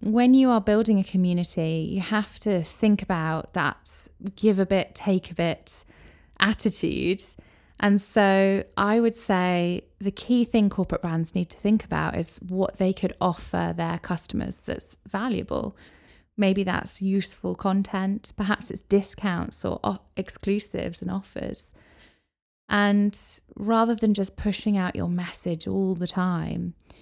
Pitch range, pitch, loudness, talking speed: 175-205 Hz, 195 Hz, -24 LUFS, 145 wpm